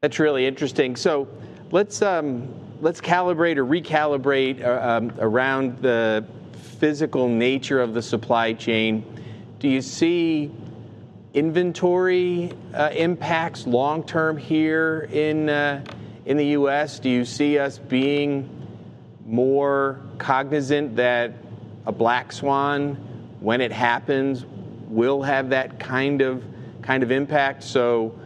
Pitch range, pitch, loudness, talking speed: 120-150 Hz, 135 Hz, -22 LUFS, 120 wpm